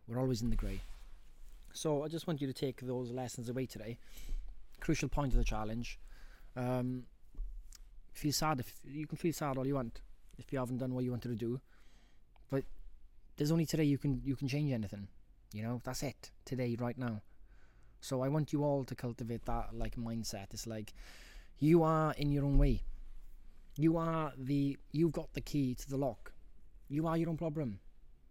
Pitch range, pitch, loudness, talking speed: 115-145 Hz, 125 Hz, -37 LUFS, 195 wpm